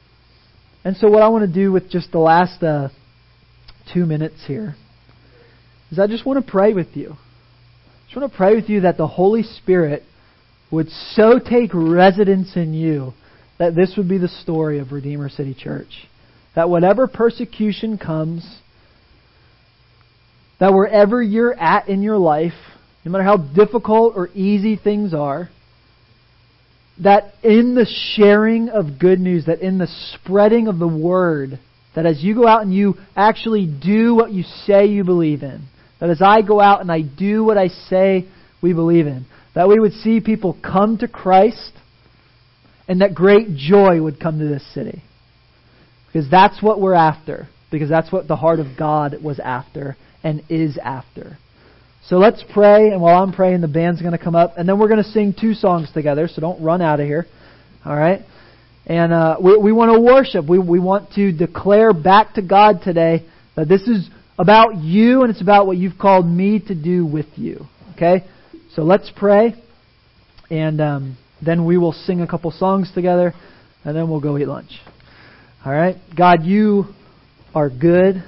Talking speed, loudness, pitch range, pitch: 180 wpm, -15 LUFS, 150-200 Hz, 175 Hz